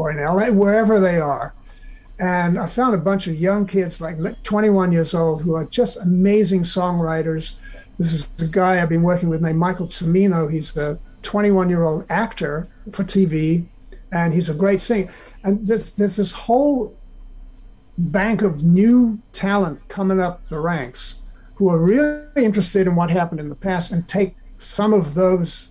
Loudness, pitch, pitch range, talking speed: -19 LUFS, 180 Hz, 165-200 Hz, 175 wpm